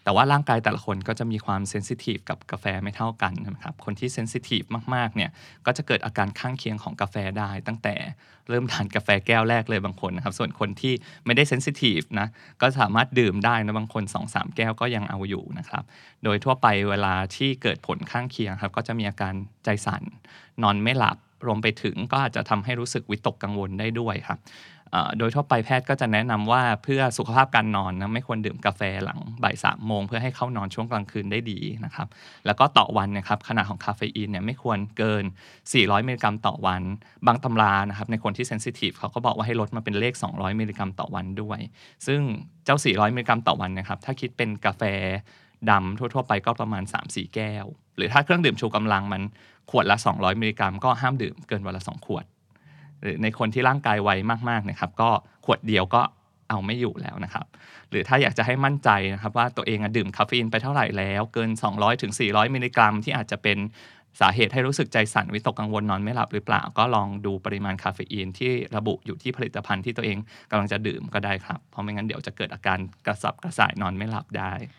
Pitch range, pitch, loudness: 100-120 Hz, 110 Hz, -25 LUFS